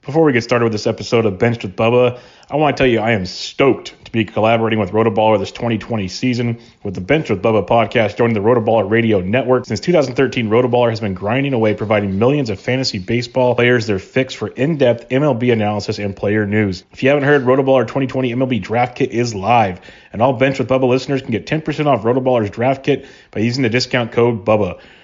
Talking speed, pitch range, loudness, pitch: 215 wpm, 110-130 Hz, -16 LUFS, 120 Hz